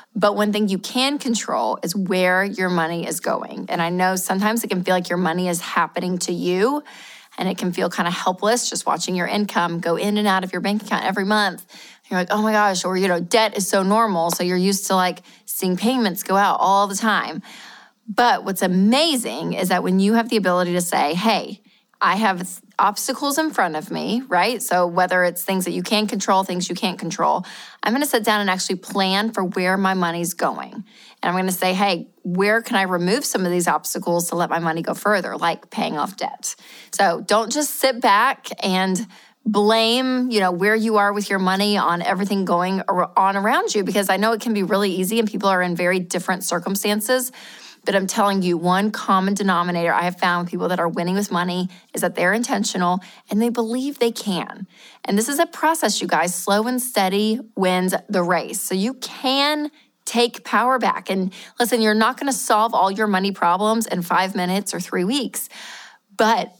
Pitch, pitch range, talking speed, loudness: 195 Hz, 180-220 Hz, 215 wpm, -20 LUFS